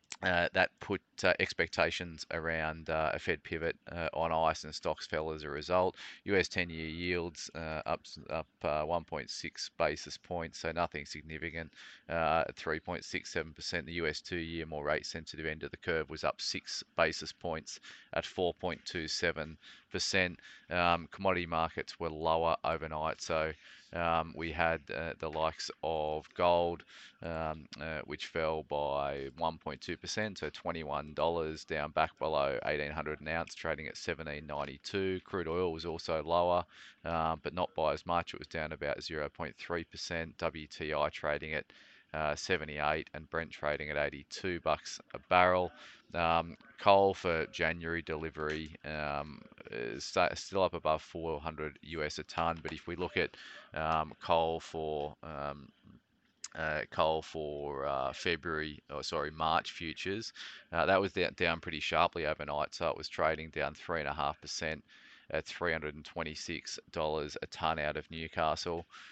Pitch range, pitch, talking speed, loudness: 75-85 Hz, 80 Hz, 150 wpm, -35 LUFS